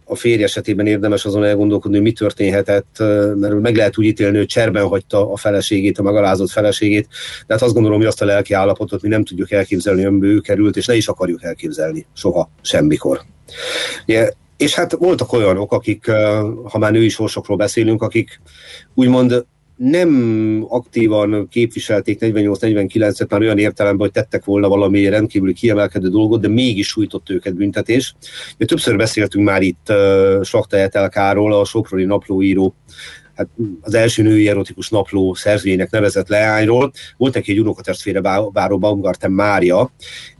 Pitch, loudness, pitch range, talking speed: 105 Hz, -15 LUFS, 100-110 Hz, 155 wpm